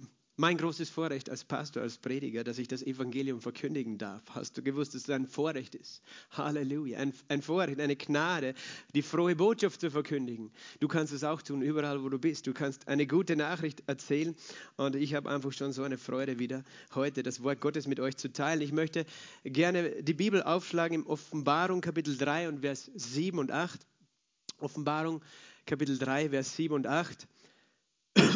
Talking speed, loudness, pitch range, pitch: 180 wpm, -33 LUFS, 135-160 Hz, 145 Hz